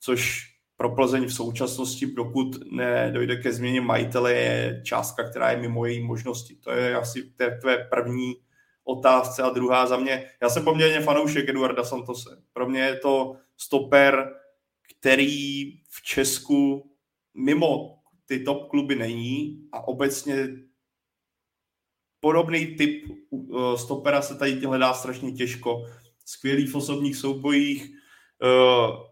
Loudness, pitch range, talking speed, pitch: -24 LUFS, 125-140 Hz, 125 wpm, 130 Hz